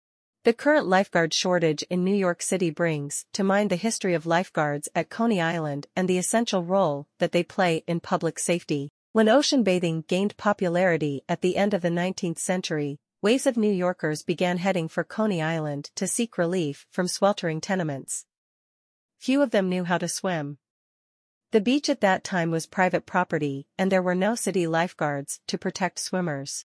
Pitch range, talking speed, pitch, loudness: 165-195 Hz, 175 wpm, 180 Hz, -25 LUFS